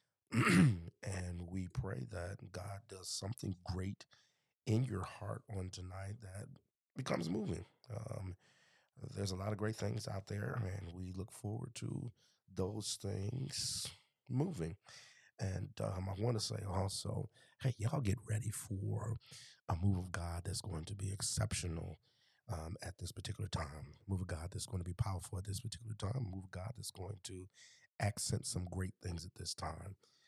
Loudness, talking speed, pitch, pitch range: -42 LUFS, 170 wpm, 100 Hz, 95-110 Hz